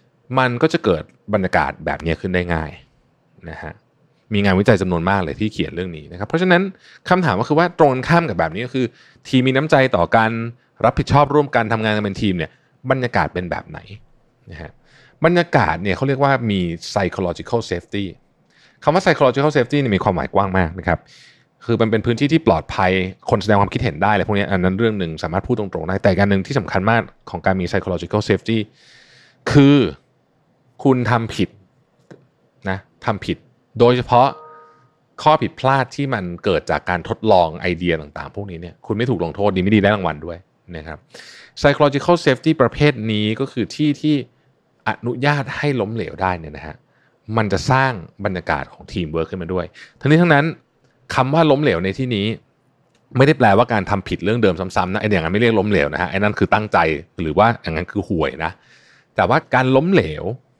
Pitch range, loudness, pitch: 95-135 Hz, -18 LUFS, 110 Hz